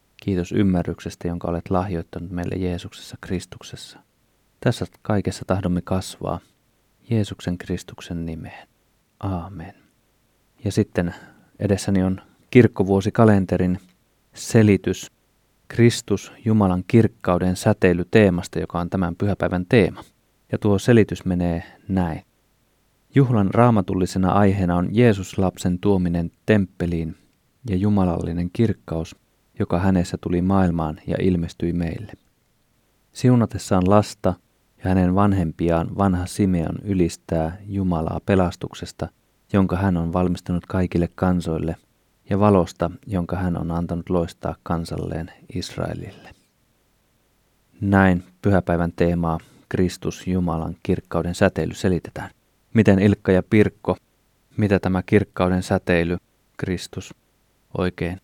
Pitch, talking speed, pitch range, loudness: 95 Hz, 100 wpm, 85-100 Hz, -21 LUFS